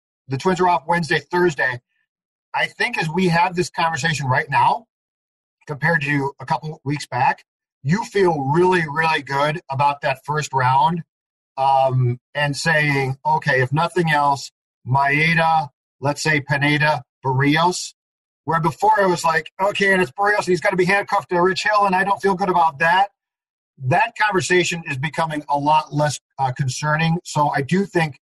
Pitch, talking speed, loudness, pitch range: 160 Hz, 170 wpm, -19 LUFS, 145-180 Hz